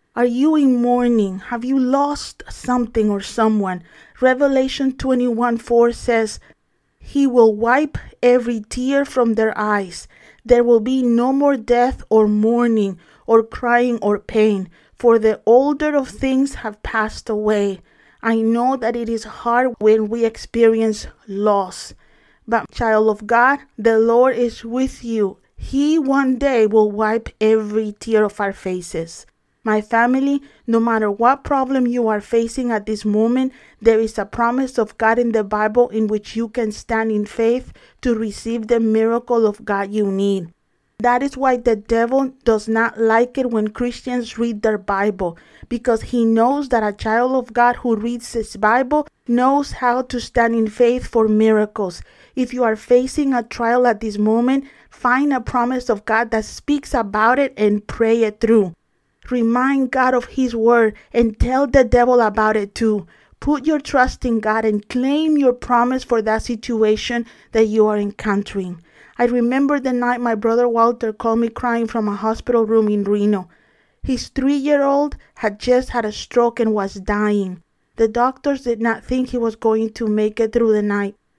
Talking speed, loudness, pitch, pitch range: 170 wpm, -18 LUFS, 230 Hz, 215-250 Hz